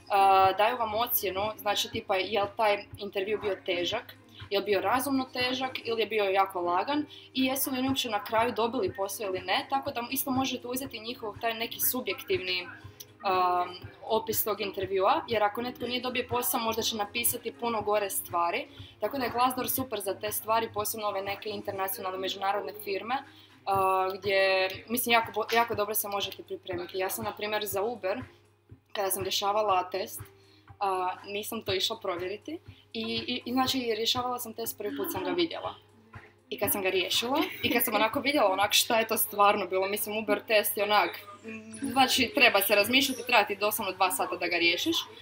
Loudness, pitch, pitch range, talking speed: -28 LUFS, 210 Hz, 195-240 Hz, 185 wpm